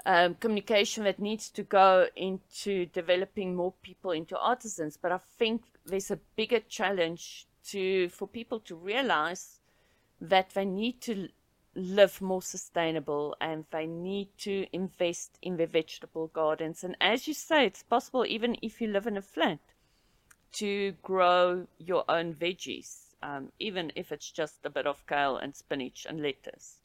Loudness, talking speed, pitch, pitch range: -30 LUFS, 160 wpm, 190 Hz, 175-215 Hz